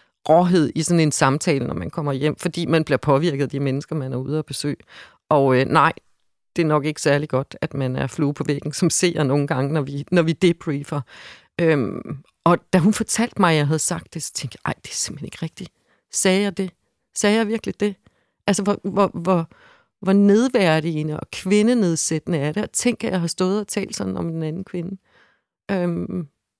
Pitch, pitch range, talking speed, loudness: 165 Hz, 145-190 Hz, 215 wpm, -21 LUFS